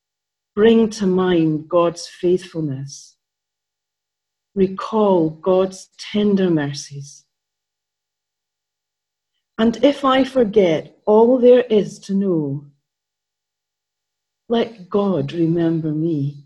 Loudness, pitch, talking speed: -18 LUFS, 155 Hz, 80 wpm